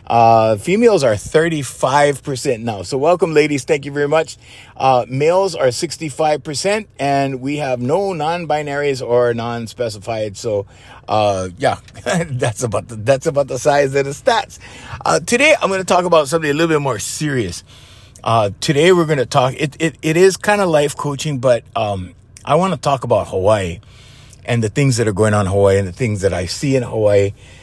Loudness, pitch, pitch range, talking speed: -16 LUFS, 135 Hz, 110-155 Hz, 190 wpm